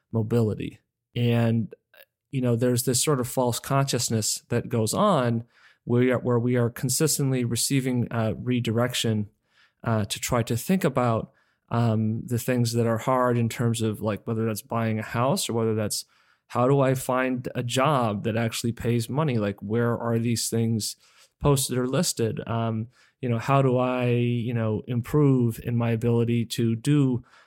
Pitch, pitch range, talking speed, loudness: 120 Hz, 115-125 Hz, 165 wpm, -25 LUFS